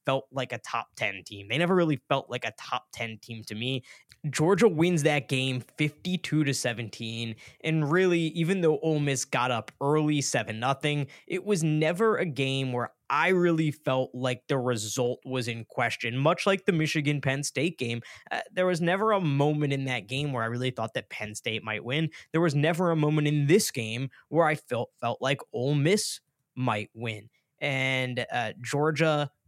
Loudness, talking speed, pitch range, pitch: -28 LUFS, 195 wpm, 125-160 Hz, 140 Hz